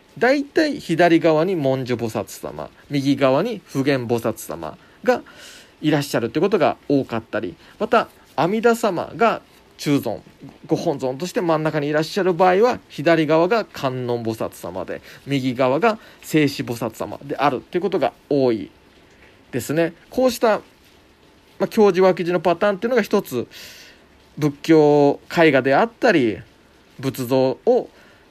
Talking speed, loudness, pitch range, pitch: 285 characters per minute, -20 LUFS, 130-195 Hz, 155 Hz